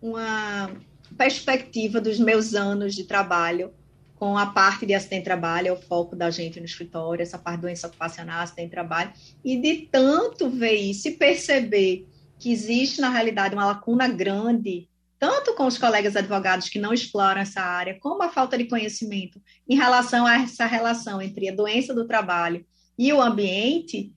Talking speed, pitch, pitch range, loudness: 165 wpm, 205 Hz, 180-240 Hz, -23 LUFS